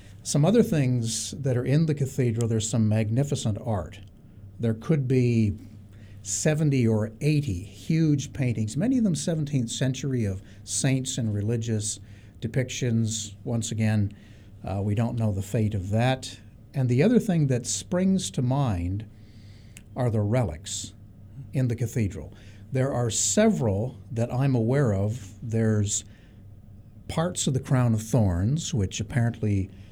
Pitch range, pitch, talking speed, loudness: 105-130 Hz, 115 Hz, 140 wpm, -26 LUFS